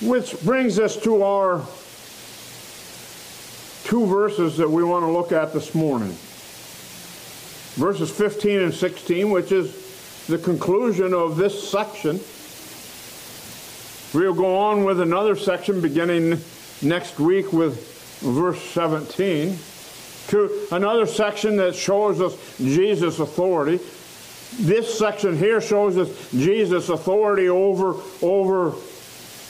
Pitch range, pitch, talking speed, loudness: 170-205 Hz, 185 Hz, 110 wpm, -21 LUFS